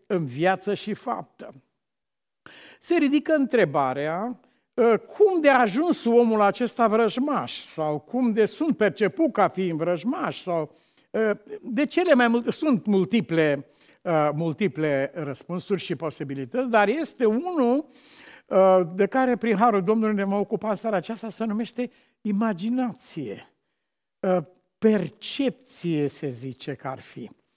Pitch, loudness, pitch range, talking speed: 215 Hz, -24 LUFS, 175-245 Hz, 120 wpm